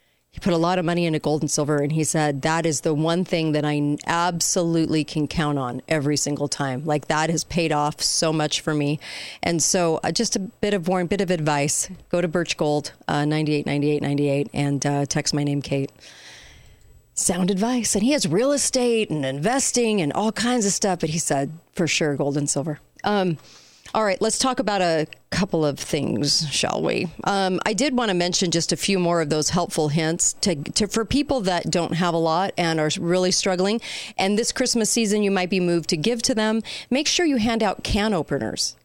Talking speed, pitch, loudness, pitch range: 220 wpm, 170 Hz, -22 LUFS, 150-200 Hz